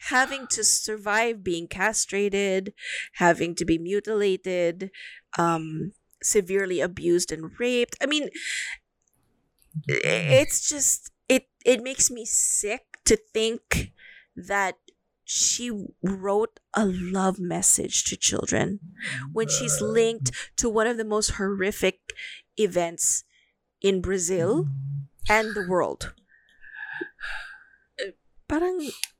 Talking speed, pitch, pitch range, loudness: 105 wpm, 205 Hz, 180-235 Hz, -25 LUFS